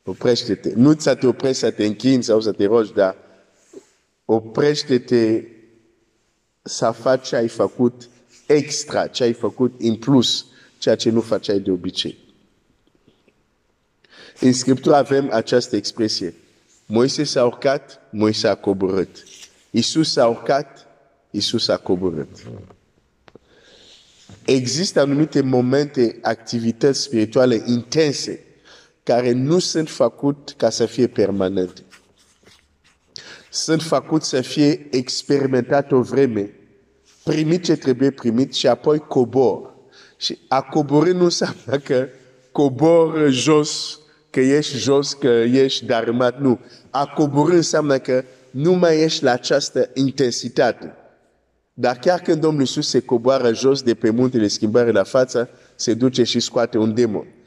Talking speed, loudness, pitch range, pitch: 125 wpm, -19 LUFS, 115-145 Hz, 130 Hz